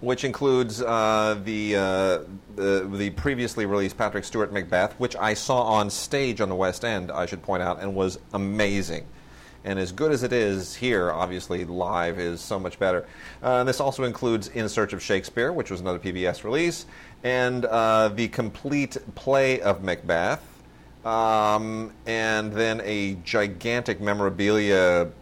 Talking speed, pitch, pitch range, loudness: 160 wpm, 105 Hz, 95-120 Hz, -25 LUFS